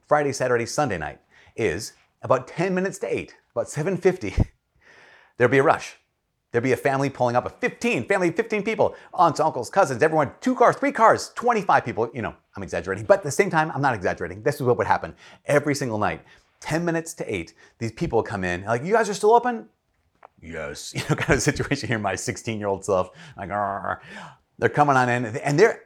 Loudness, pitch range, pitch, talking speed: -23 LUFS, 125-195 Hz, 150 Hz, 210 wpm